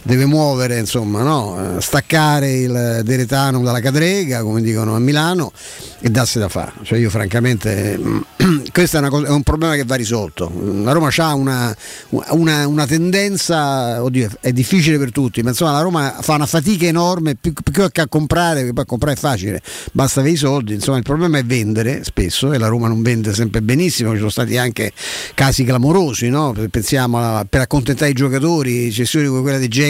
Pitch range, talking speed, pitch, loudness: 115-150 Hz, 190 wpm, 135 Hz, -16 LUFS